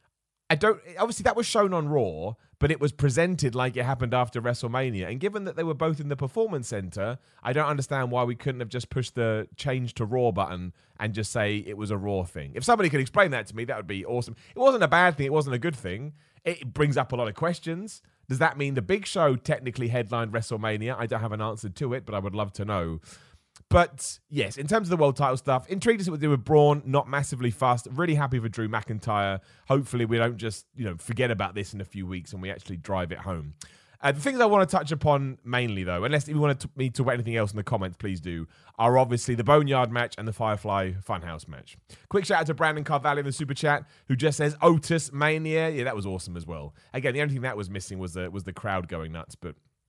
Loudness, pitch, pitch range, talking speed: -27 LUFS, 125 Hz, 105-150 Hz, 255 wpm